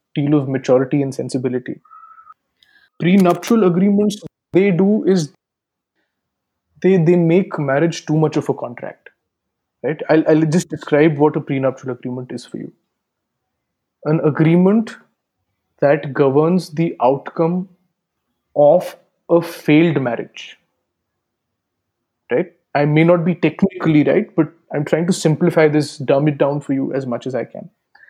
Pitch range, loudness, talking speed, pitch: 135-175 Hz, -16 LUFS, 135 wpm, 155 Hz